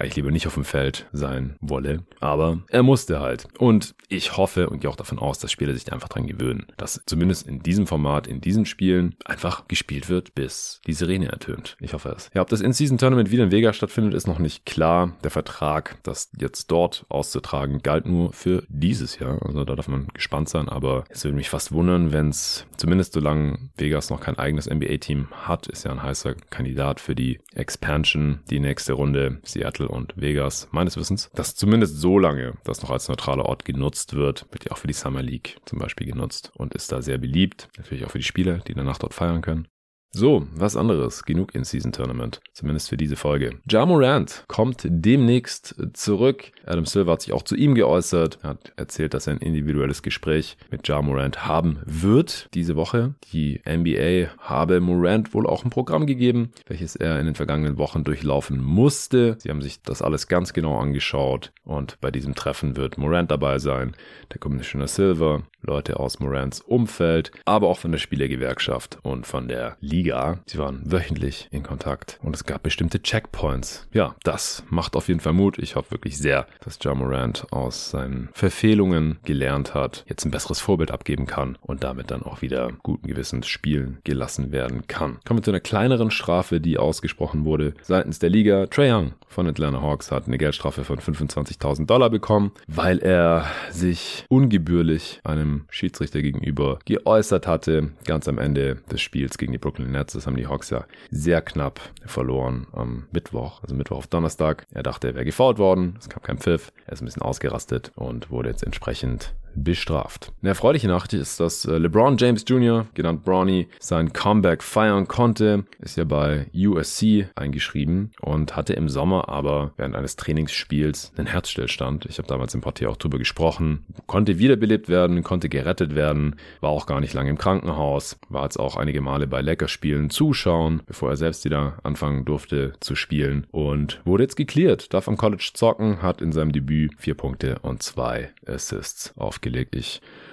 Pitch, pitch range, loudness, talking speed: 75 Hz, 70-90 Hz, -23 LUFS, 190 wpm